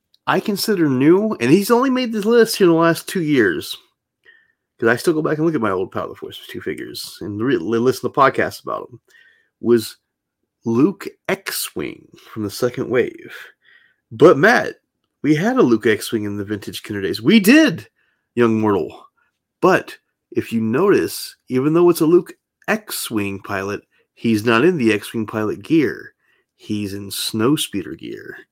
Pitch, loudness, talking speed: 155 Hz, -18 LUFS, 185 wpm